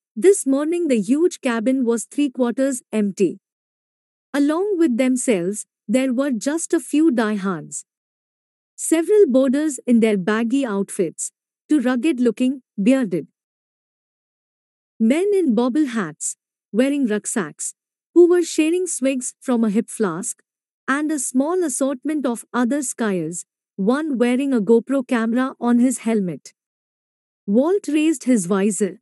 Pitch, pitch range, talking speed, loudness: 255 Hz, 225-295 Hz, 125 wpm, -20 LUFS